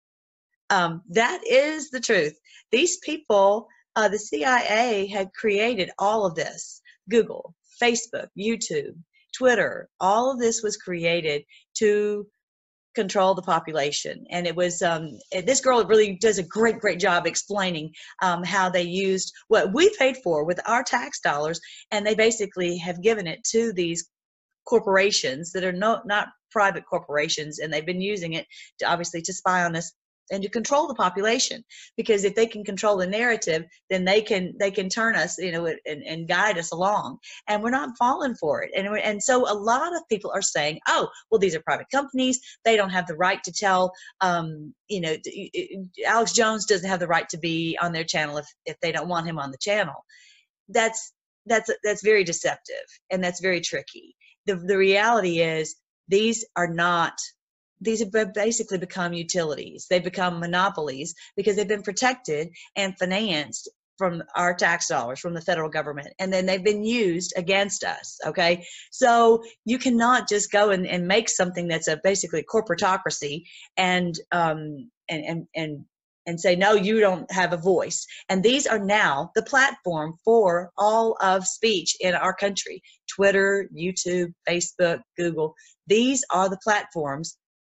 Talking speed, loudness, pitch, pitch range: 170 wpm, -23 LUFS, 195 Hz, 175-225 Hz